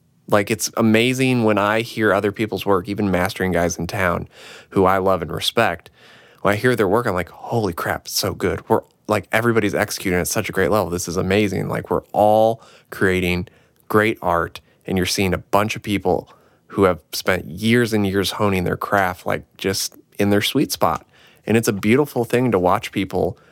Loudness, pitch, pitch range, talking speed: -20 LUFS, 100 Hz, 95-110 Hz, 200 wpm